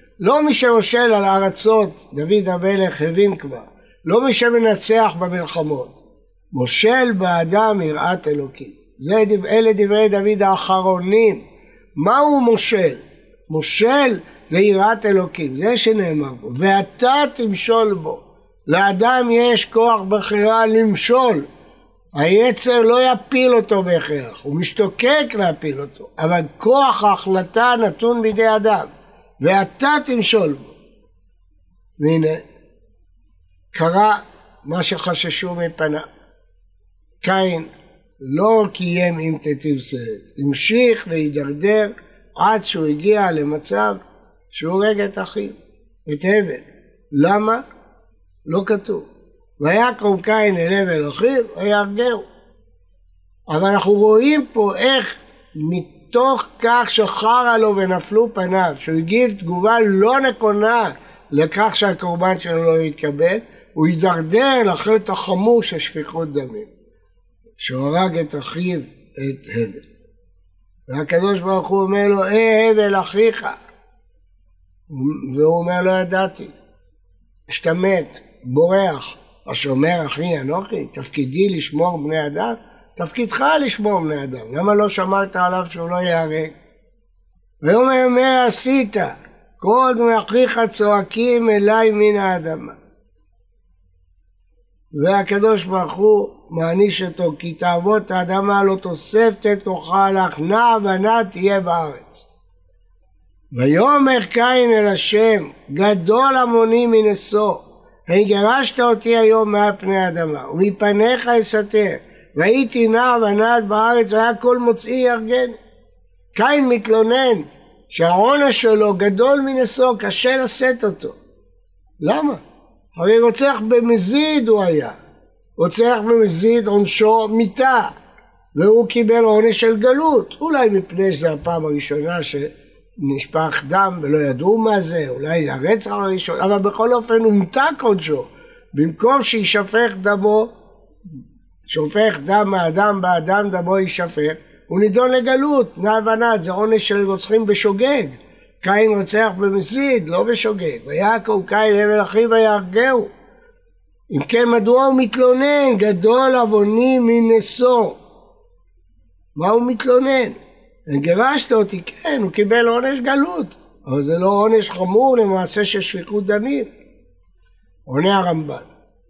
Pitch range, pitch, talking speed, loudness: 165-230 Hz, 205 Hz, 110 wpm, -16 LUFS